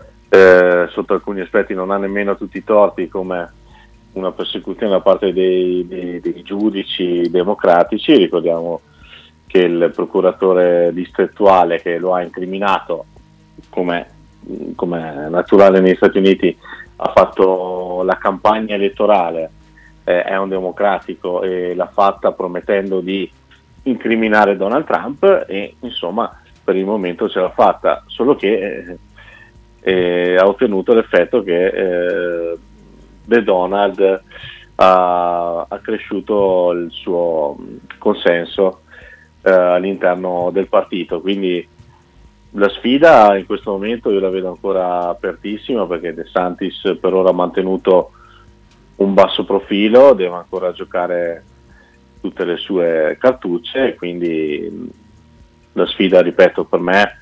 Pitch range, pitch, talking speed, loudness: 85-100 Hz, 90 Hz, 120 wpm, -15 LUFS